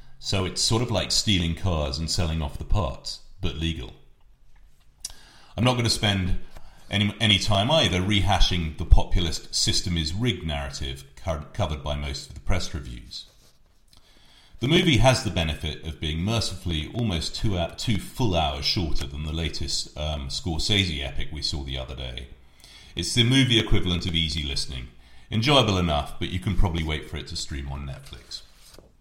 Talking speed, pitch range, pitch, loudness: 170 wpm, 75-100 Hz, 85 Hz, -25 LUFS